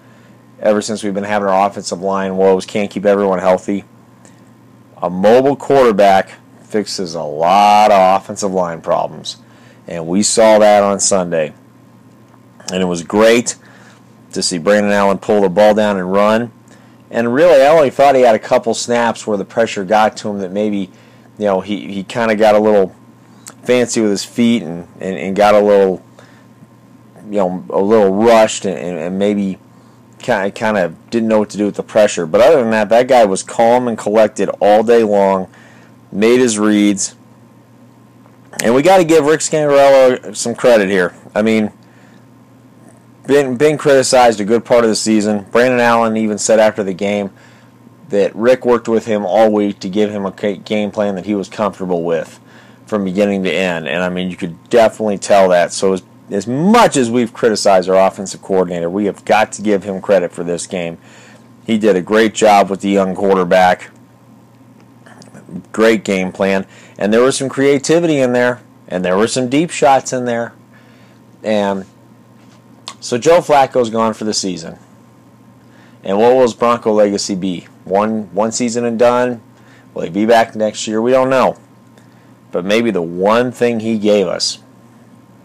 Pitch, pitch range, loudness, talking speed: 105 Hz, 100-120 Hz, -13 LUFS, 180 wpm